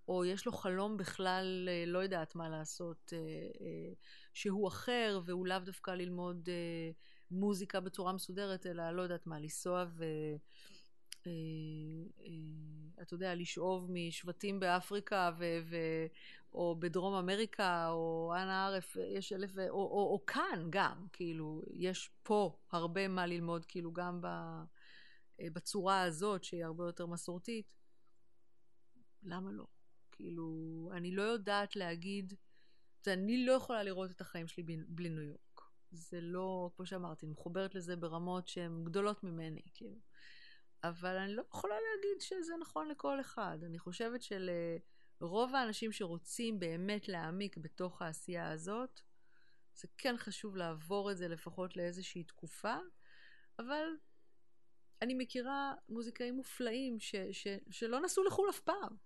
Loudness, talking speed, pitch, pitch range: -41 LUFS, 130 wpm, 185 Hz, 170-205 Hz